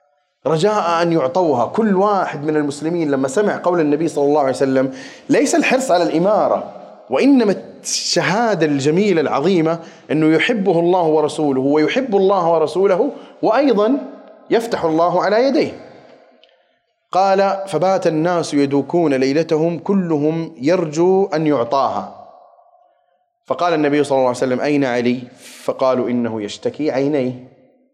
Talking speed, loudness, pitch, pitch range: 120 wpm, -17 LUFS, 165 Hz, 145-195 Hz